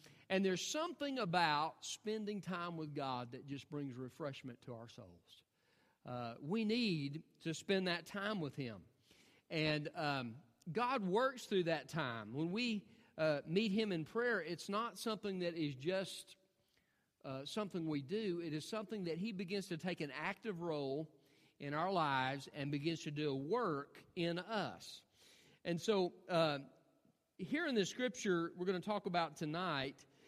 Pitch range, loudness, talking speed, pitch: 145-200 Hz, -41 LUFS, 165 wpm, 170 Hz